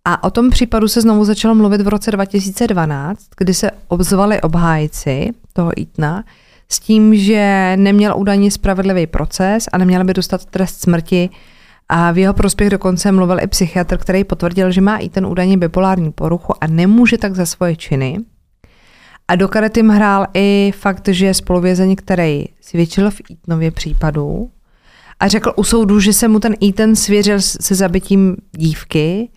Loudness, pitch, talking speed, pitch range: -13 LUFS, 195 Hz, 165 wpm, 180-205 Hz